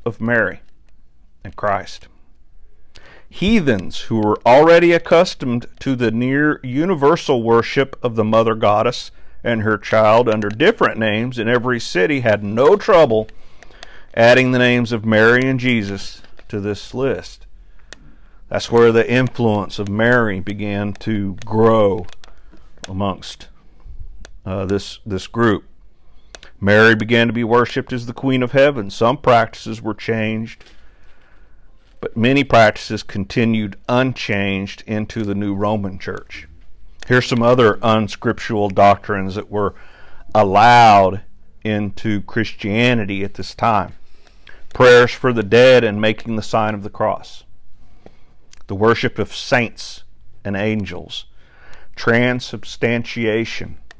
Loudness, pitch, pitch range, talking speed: -16 LUFS, 110 Hz, 100-120 Hz, 120 wpm